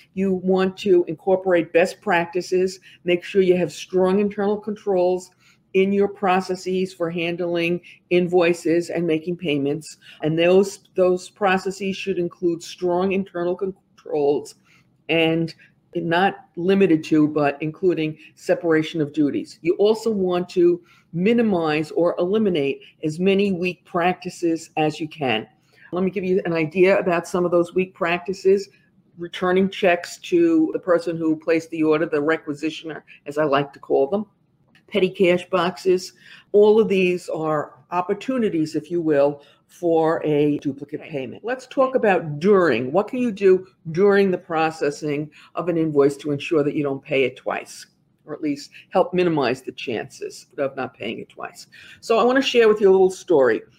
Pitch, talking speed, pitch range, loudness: 175 Hz, 160 wpm, 160-190 Hz, -21 LUFS